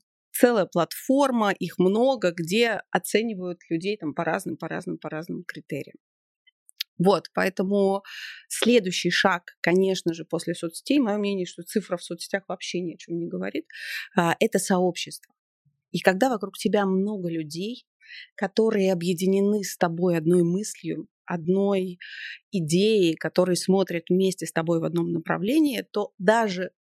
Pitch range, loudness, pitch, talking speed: 170-210 Hz, -25 LUFS, 185 Hz, 135 wpm